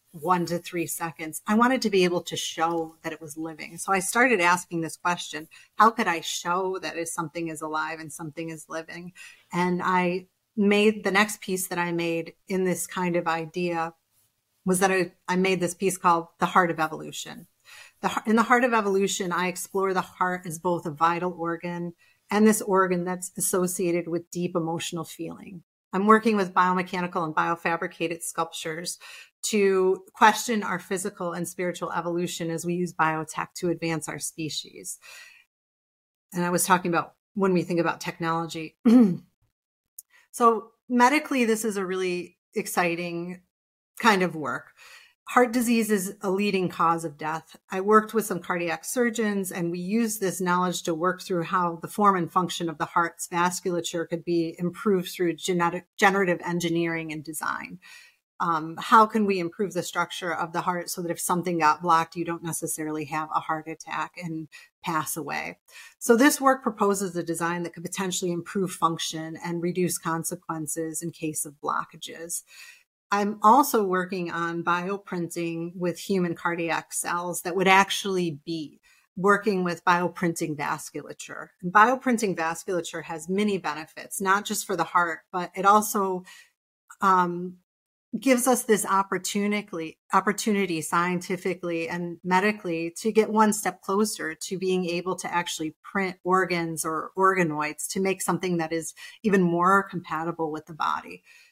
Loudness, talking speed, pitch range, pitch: -25 LUFS, 160 wpm, 165-195 Hz, 175 Hz